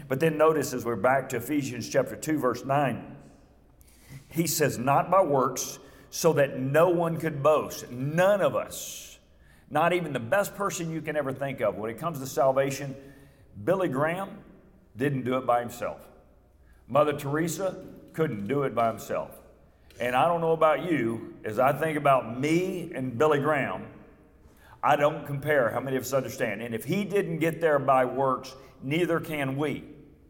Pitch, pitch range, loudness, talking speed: 140 Hz, 130-160 Hz, -27 LUFS, 175 wpm